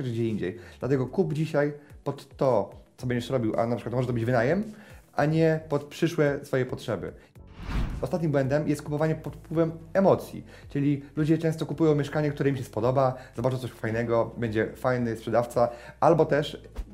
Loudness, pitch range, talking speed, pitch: -27 LUFS, 120-155 Hz, 165 wpm, 140 Hz